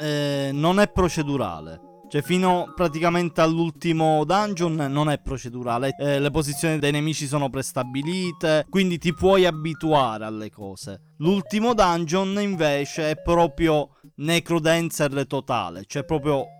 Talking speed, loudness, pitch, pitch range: 125 wpm, -23 LUFS, 155 Hz, 140-170 Hz